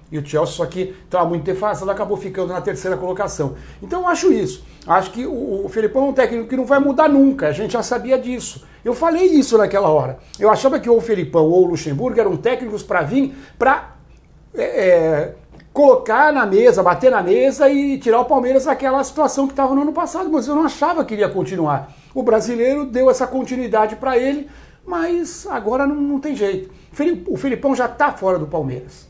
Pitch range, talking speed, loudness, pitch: 190-285 Hz, 205 wpm, -17 LUFS, 255 Hz